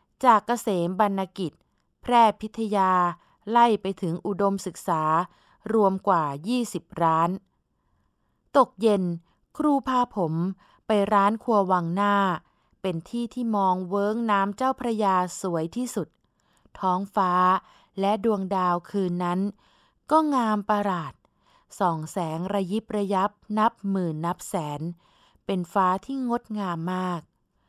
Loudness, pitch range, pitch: -25 LUFS, 180-215 Hz, 195 Hz